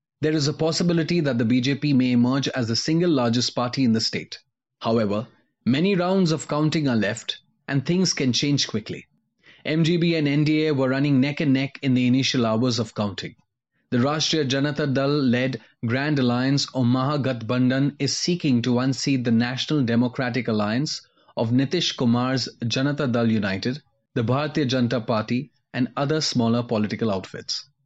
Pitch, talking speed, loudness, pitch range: 130 Hz, 165 wpm, -23 LUFS, 120-145 Hz